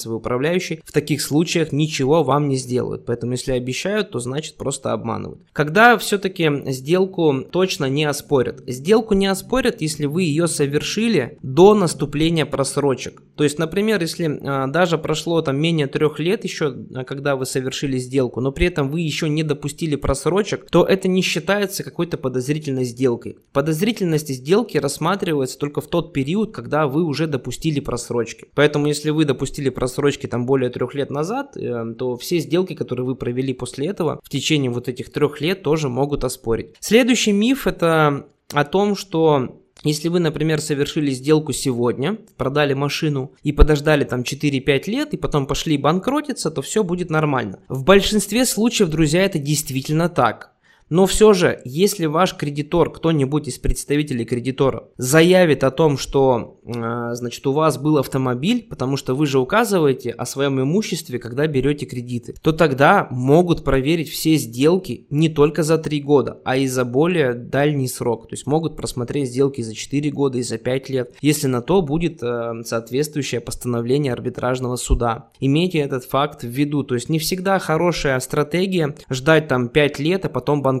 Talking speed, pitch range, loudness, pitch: 165 wpm, 130-165 Hz, -19 LUFS, 145 Hz